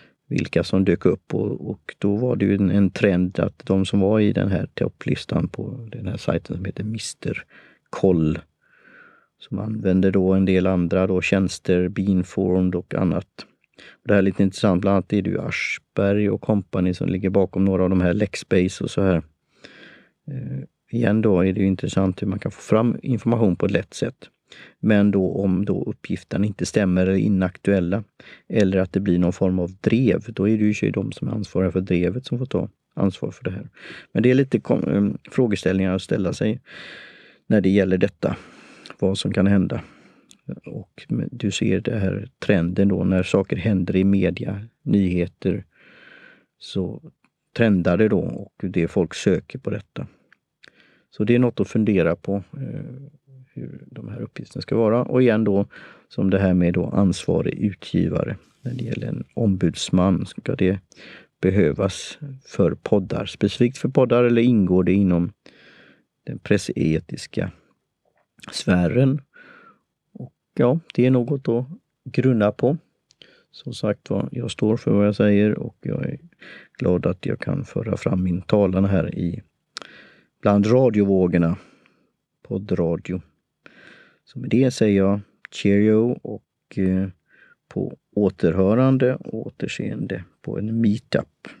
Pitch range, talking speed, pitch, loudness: 95-110 Hz, 160 wpm, 100 Hz, -21 LUFS